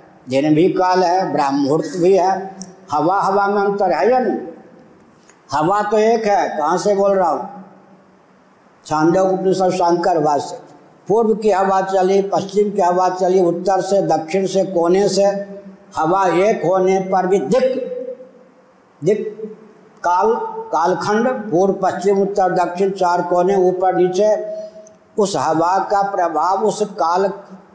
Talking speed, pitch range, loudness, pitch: 140 wpm, 180-210 Hz, -16 LUFS, 195 Hz